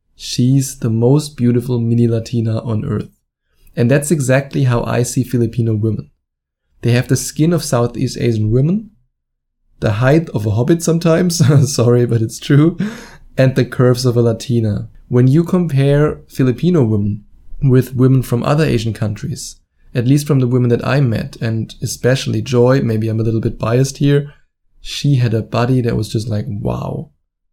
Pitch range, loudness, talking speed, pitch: 115-140 Hz, -15 LUFS, 170 wpm, 125 Hz